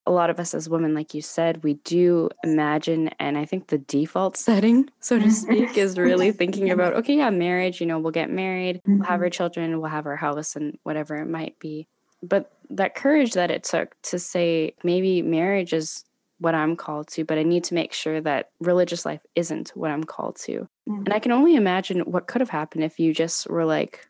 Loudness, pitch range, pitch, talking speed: -23 LUFS, 160-190 Hz, 170 Hz, 220 wpm